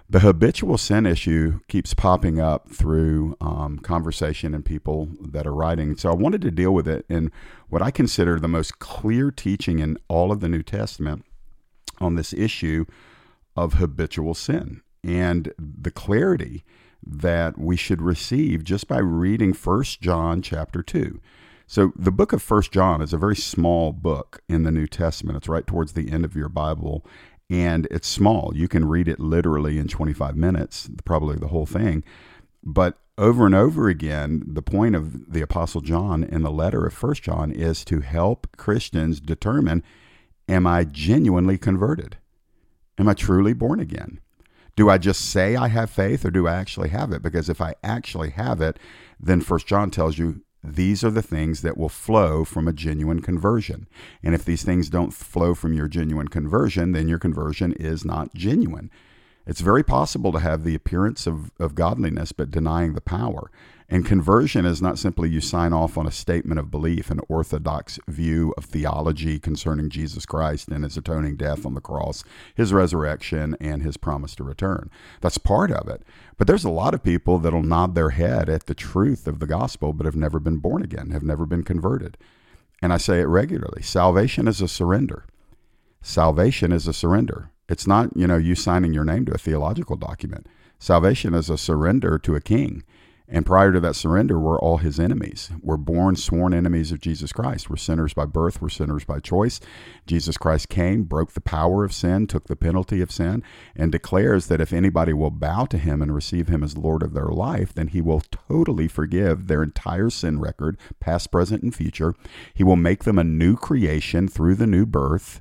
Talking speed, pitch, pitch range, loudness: 190 wpm, 85 Hz, 80-95 Hz, -22 LUFS